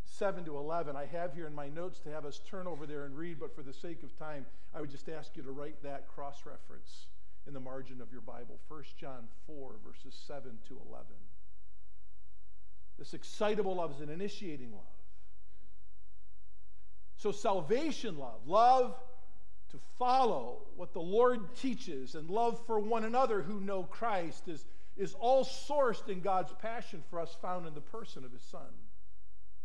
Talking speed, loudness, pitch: 175 wpm, -36 LUFS, 150 Hz